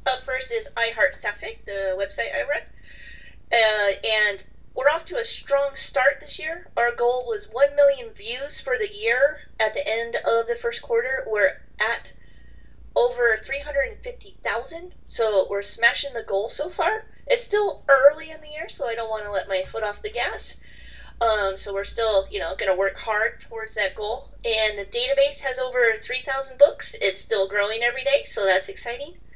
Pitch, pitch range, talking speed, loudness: 240 Hz, 210-290 Hz, 185 wpm, -23 LUFS